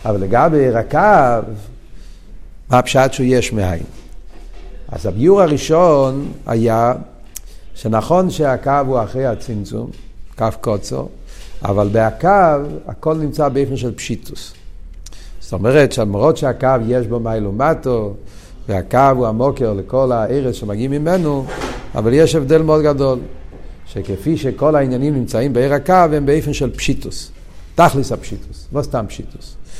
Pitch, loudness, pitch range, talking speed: 125 Hz, -15 LUFS, 110-145 Hz, 125 wpm